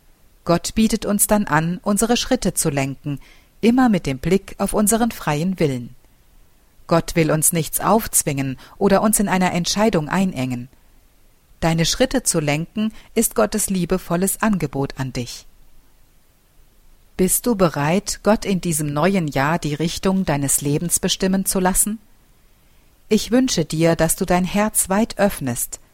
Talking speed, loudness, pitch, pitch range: 145 wpm, -19 LUFS, 180 Hz, 150-205 Hz